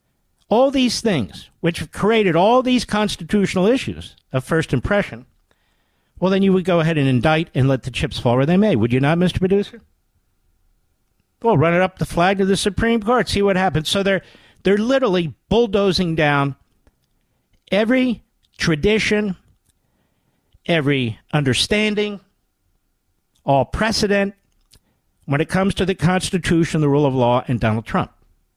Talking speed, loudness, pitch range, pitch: 150 wpm, -18 LUFS, 140-205 Hz, 180 Hz